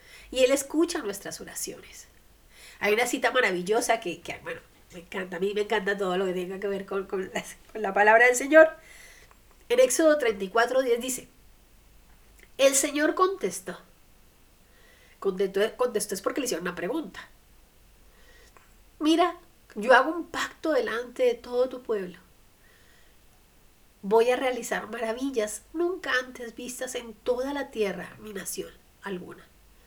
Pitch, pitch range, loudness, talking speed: 235 Hz, 205-275 Hz, -26 LUFS, 145 wpm